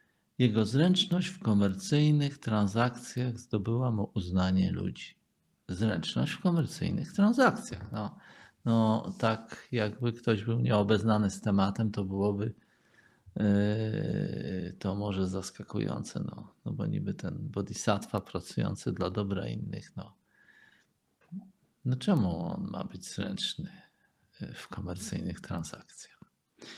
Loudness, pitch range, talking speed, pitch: -31 LUFS, 100-130 Hz, 110 wpm, 110 Hz